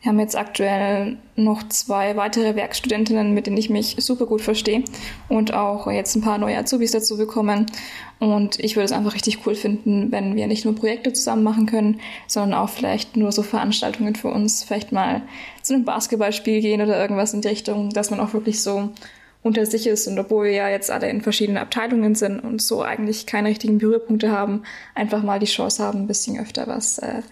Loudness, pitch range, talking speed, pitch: -21 LUFS, 210-225 Hz, 205 wpm, 215 Hz